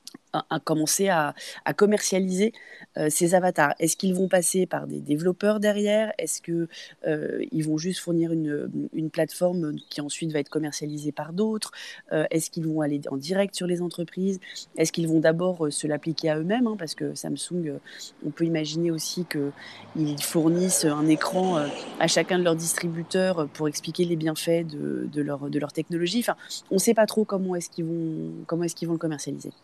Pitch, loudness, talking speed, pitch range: 165 Hz, -26 LUFS, 190 wpm, 155-185 Hz